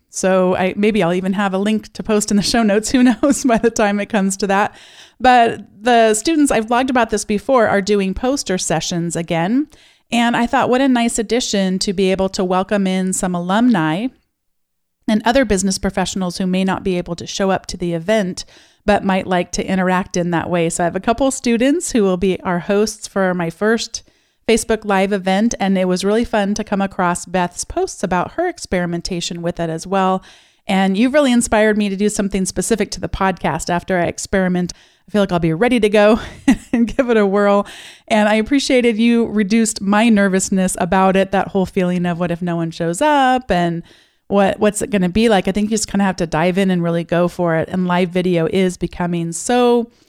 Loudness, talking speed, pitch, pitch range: -17 LUFS, 220 wpm, 200 Hz, 185-225 Hz